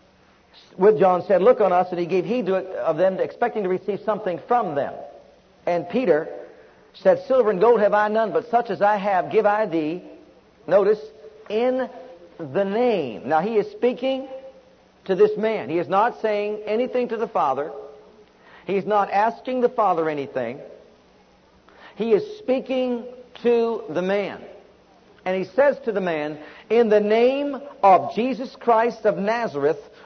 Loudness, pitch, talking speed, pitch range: -22 LUFS, 215 Hz, 165 wpm, 190-245 Hz